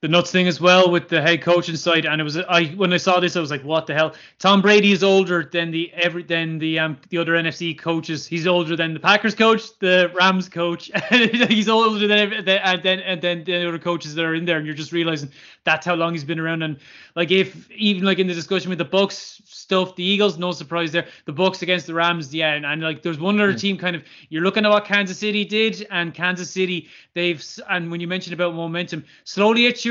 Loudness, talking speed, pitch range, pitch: -19 LUFS, 250 wpm, 165-195 Hz, 175 Hz